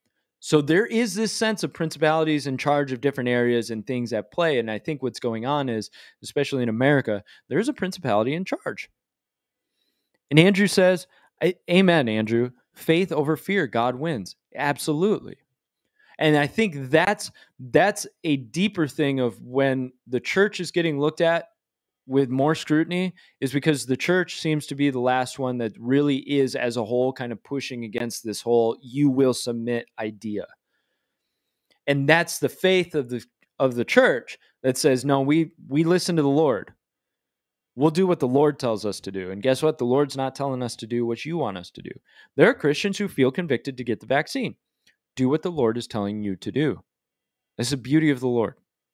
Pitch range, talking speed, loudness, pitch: 120-160 Hz, 190 wpm, -23 LUFS, 140 Hz